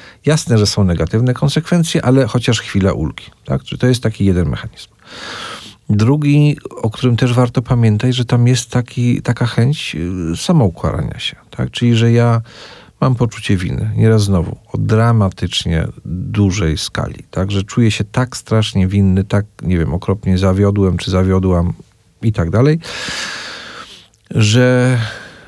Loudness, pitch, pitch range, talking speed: -15 LUFS, 110 Hz, 95-125 Hz, 140 wpm